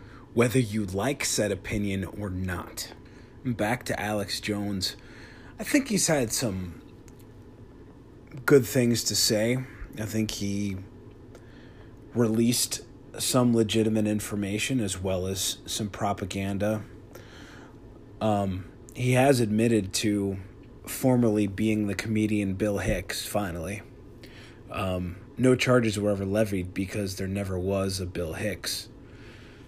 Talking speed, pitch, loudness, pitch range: 115 wpm, 110 Hz, -27 LUFS, 100-120 Hz